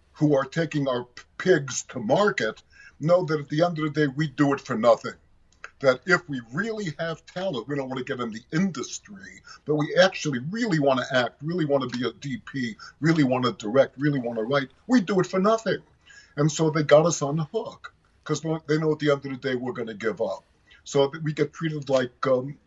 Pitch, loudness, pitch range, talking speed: 150 Hz, -25 LUFS, 135-165 Hz, 235 wpm